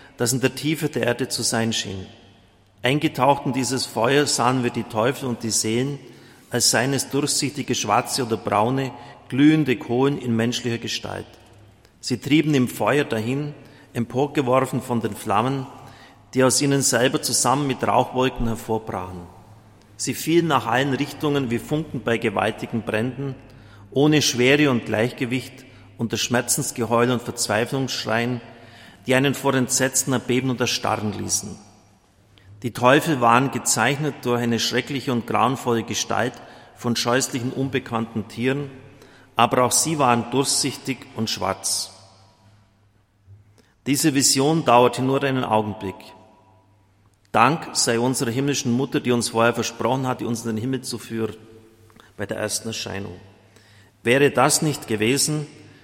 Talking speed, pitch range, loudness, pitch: 135 wpm, 110-135 Hz, -21 LUFS, 120 Hz